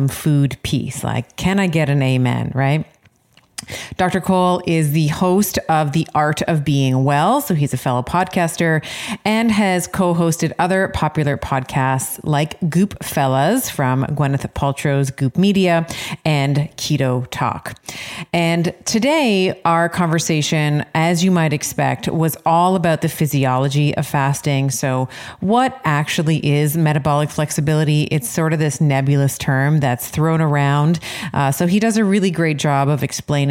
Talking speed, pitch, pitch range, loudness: 150 wpm, 155 Hz, 140-175 Hz, -17 LUFS